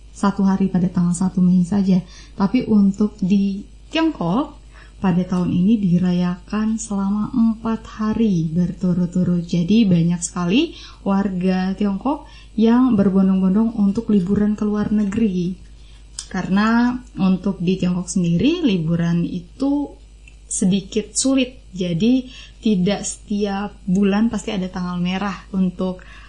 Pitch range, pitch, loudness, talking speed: 180-220 Hz, 195 Hz, -19 LUFS, 110 wpm